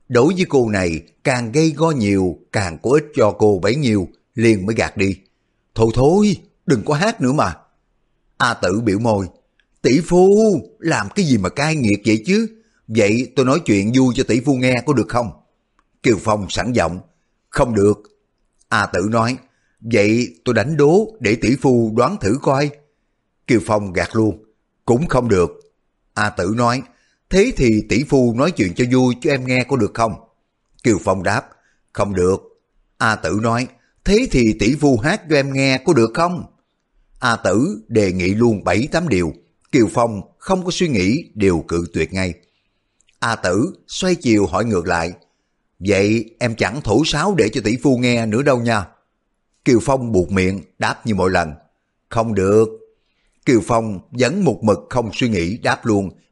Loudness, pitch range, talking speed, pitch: -17 LUFS, 100-135 Hz, 185 wpm, 115 Hz